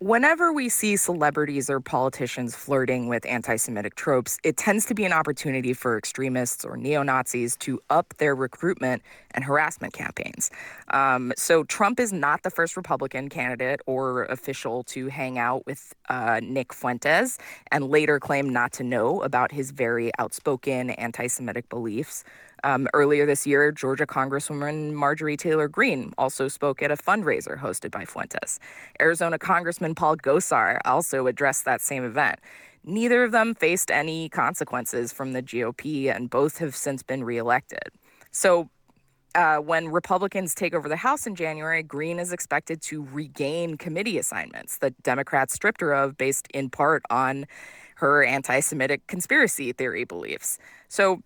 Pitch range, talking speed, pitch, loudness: 130-165 Hz, 155 wpm, 145 Hz, -25 LUFS